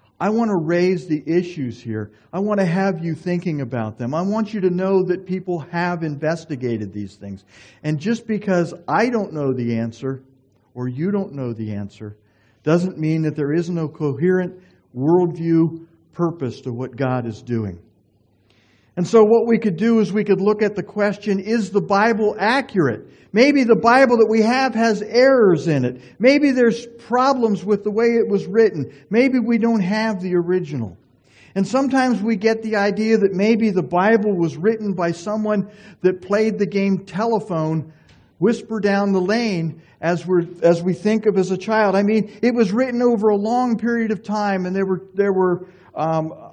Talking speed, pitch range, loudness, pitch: 185 wpm, 155-215 Hz, -19 LUFS, 185 Hz